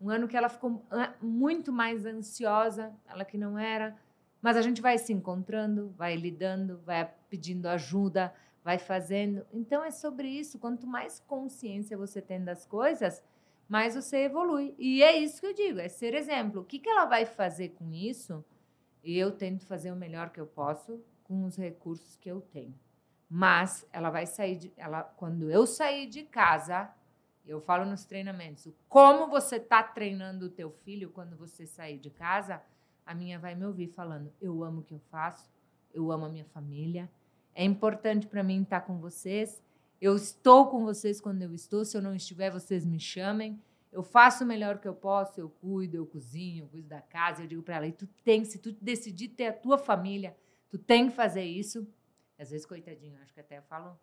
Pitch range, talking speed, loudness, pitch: 170-225 Hz, 195 wpm, -30 LUFS, 195 Hz